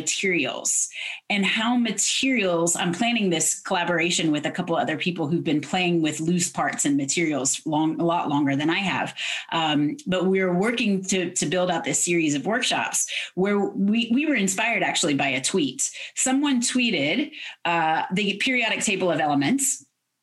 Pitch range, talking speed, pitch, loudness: 165-230 Hz, 170 wpm, 185 Hz, -23 LUFS